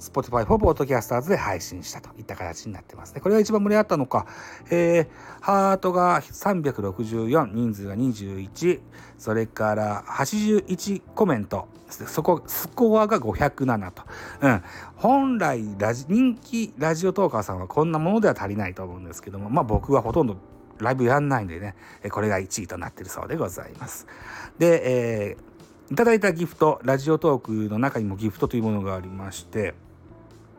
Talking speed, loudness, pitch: 345 characters per minute, -24 LUFS, 120 Hz